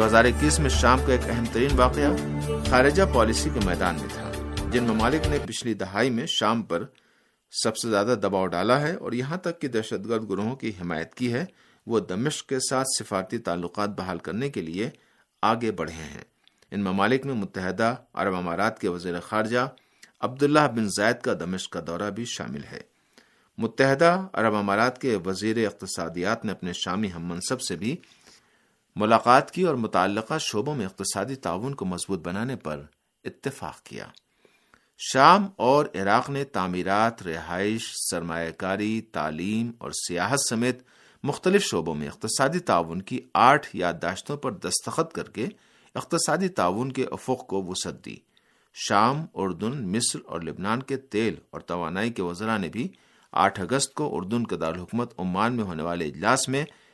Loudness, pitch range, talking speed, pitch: -25 LUFS, 90-125 Hz, 165 wpm, 110 Hz